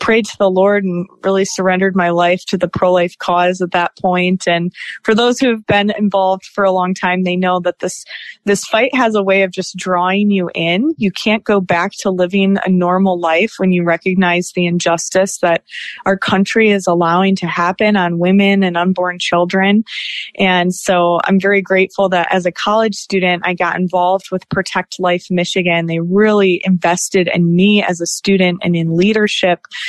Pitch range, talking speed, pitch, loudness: 180-195 Hz, 190 wpm, 185 Hz, -14 LUFS